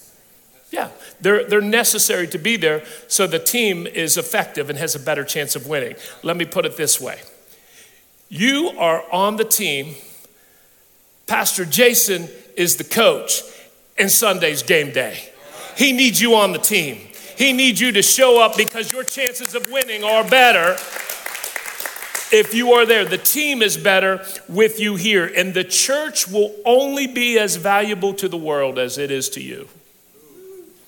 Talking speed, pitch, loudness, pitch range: 165 wpm, 215 Hz, -17 LUFS, 185-250 Hz